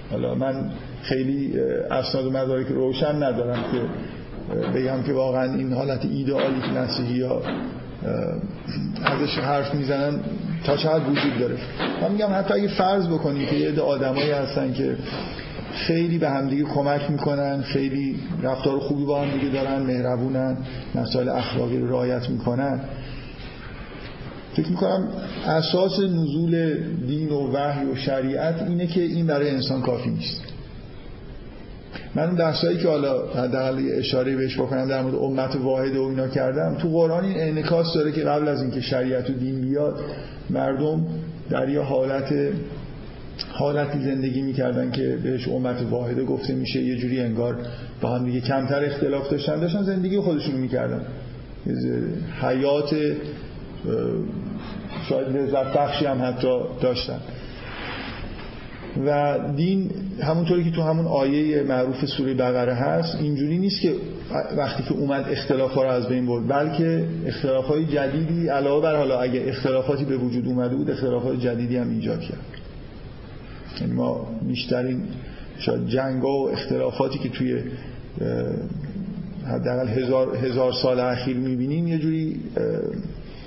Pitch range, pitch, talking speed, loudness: 130-150 Hz, 135 Hz, 140 wpm, -24 LUFS